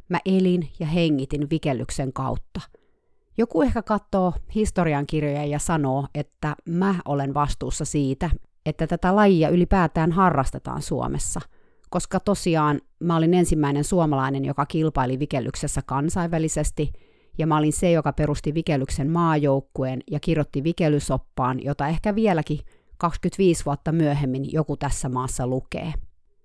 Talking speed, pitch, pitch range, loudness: 125 wpm, 155 Hz, 140-175 Hz, -23 LUFS